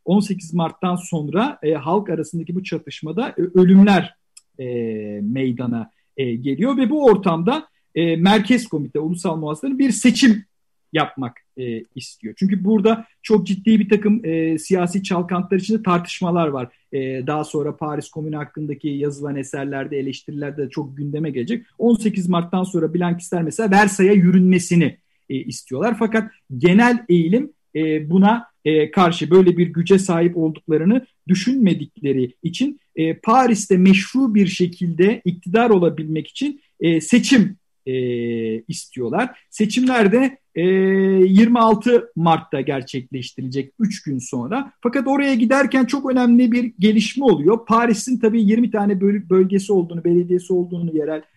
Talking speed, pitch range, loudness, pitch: 125 wpm, 155-220 Hz, -18 LUFS, 180 Hz